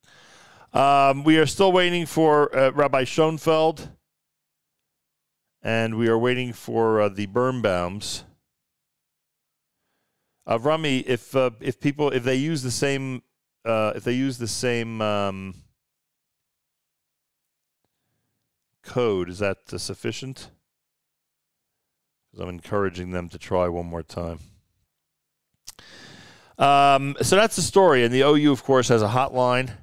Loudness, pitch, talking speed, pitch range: -22 LUFS, 125 Hz, 125 wpm, 100-140 Hz